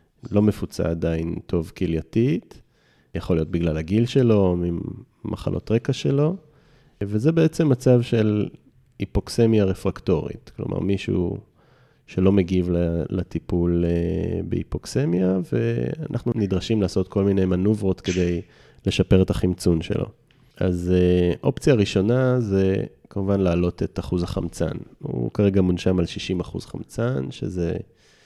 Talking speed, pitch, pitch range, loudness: 115 wpm, 95 Hz, 90-115 Hz, -23 LUFS